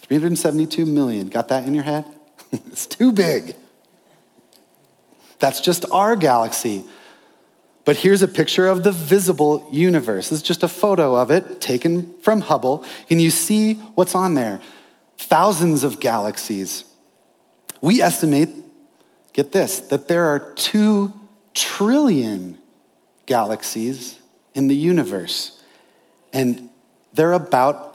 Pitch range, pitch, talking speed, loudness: 140-190 Hz, 160 Hz, 120 wpm, -19 LUFS